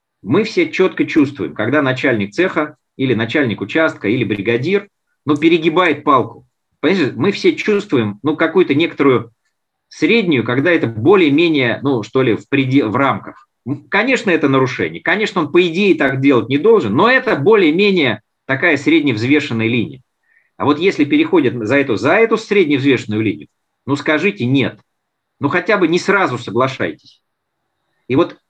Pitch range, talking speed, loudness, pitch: 130-220 Hz, 150 wpm, -15 LUFS, 155 Hz